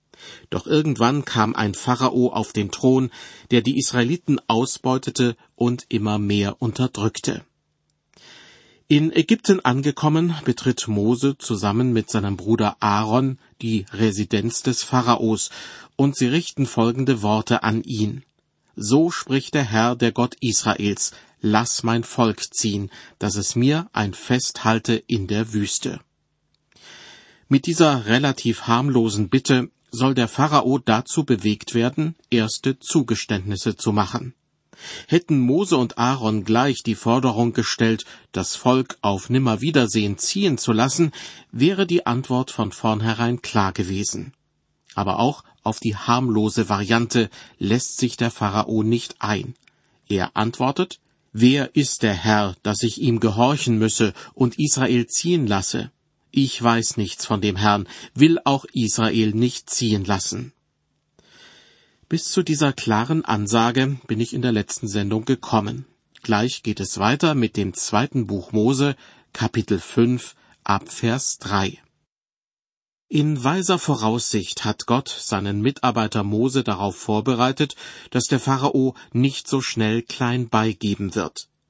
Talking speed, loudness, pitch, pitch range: 130 wpm, -21 LUFS, 120 Hz, 110-130 Hz